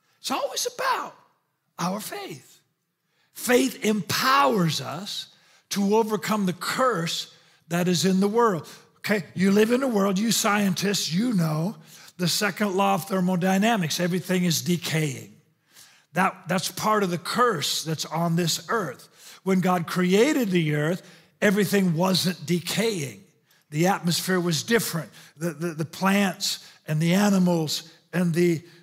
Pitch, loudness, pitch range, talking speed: 185 Hz, -24 LUFS, 165-205 Hz, 135 wpm